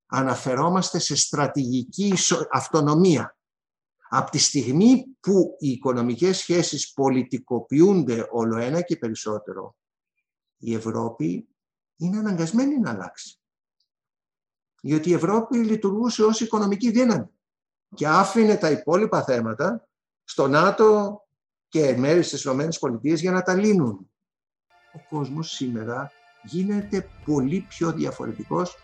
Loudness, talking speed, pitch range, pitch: -22 LUFS, 105 wpm, 135-195 Hz, 165 Hz